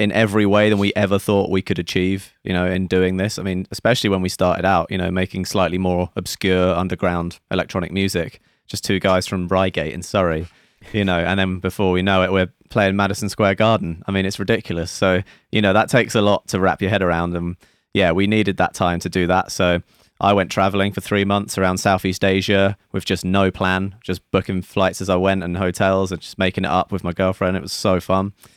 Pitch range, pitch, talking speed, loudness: 90-100 Hz, 95 Hz, 230 wpm, -19 LUFS